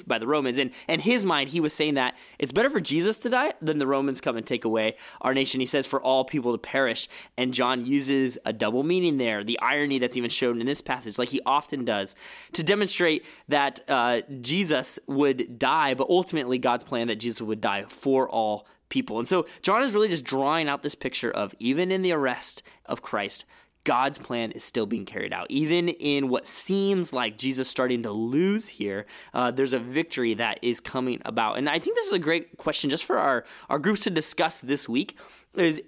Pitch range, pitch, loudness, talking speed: 125-165 Hz, 135 Hz, -25 LUFS, 215 wpm